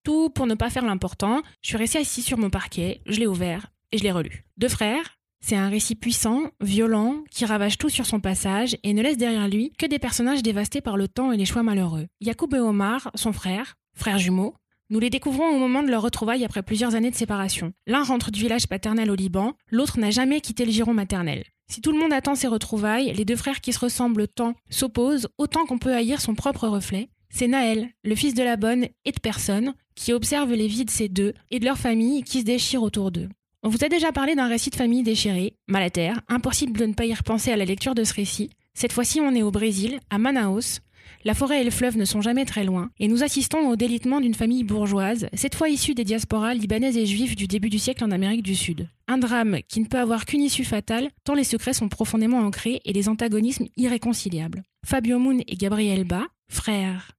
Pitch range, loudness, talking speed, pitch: 210-255 Hz, -24 LUFS, 235 wpm, 230 Hz